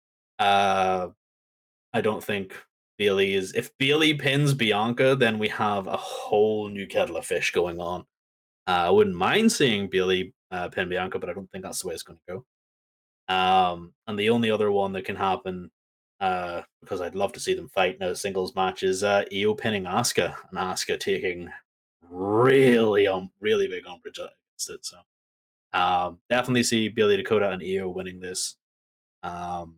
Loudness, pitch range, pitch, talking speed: -25 LUFS, 90-140 Hz, 100 Hz, 175 wpm